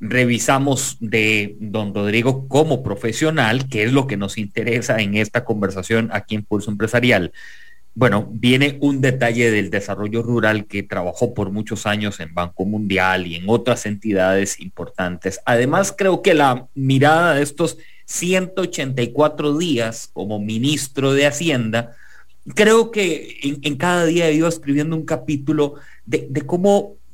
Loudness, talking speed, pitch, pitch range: -18 LUFS, 145 wpm, 120 Hz, 105-150 Hz